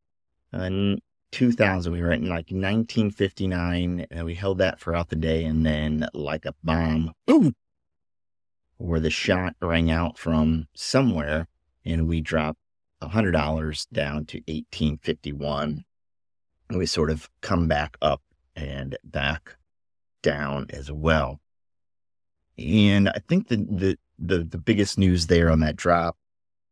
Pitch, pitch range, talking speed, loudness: 85 Hz, 80-95 Hz, 140 wpm, -25 LUFS